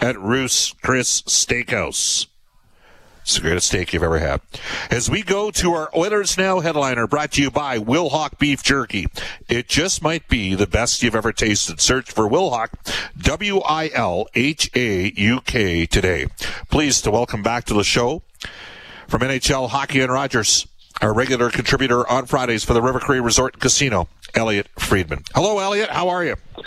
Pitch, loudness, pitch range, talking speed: 125 Hz, -19 LUFS, 105-145 Hz, 175 wpm